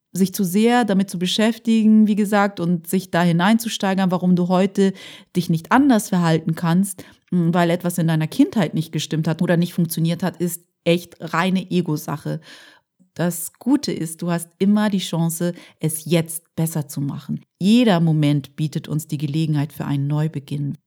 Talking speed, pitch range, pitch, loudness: 165 wpm, 160-195 Hz, 175 Hz, -20 LUFS